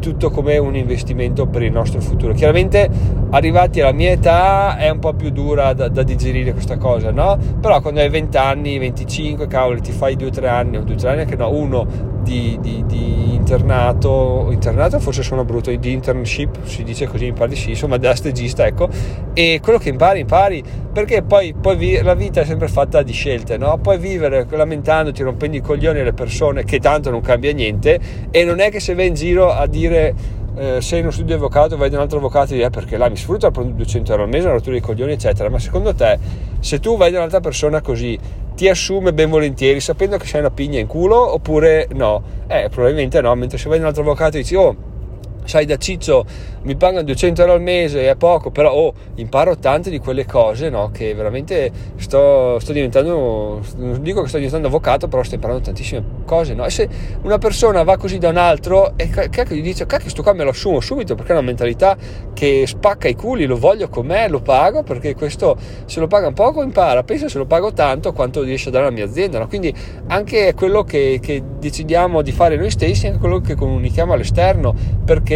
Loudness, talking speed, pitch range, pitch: -16 LUFS, 220 wpm, 115-155 Hz, 130 Hz